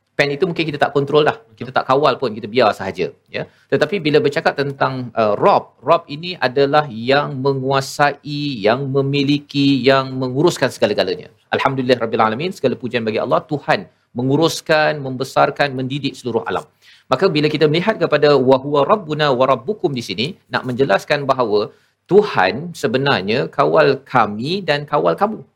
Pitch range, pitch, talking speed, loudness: 130-150 Hz, 140 Hz, 155 wpm, -17 LUFS